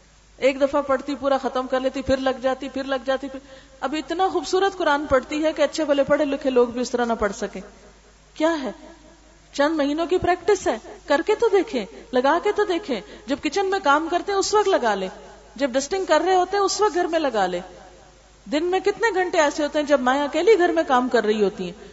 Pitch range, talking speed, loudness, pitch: 260-350 Hz, 235 wpm, -22 LUFS, 285 Hz